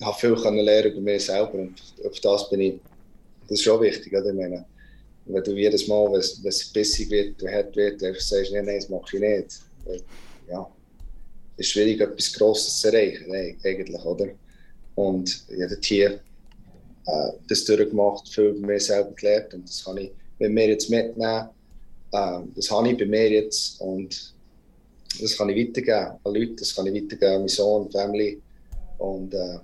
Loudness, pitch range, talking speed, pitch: -23 LUFS, 95-105 Hz, 190 wpm, 100 Hz